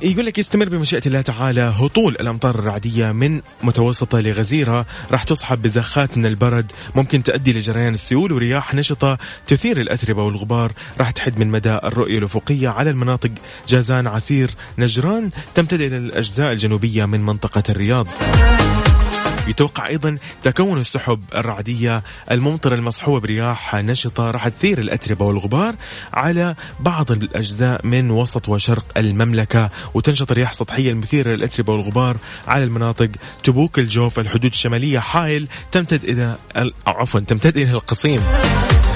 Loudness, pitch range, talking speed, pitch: -18 LUFS, 110-135 Hz, 130 wpm, 120 Hz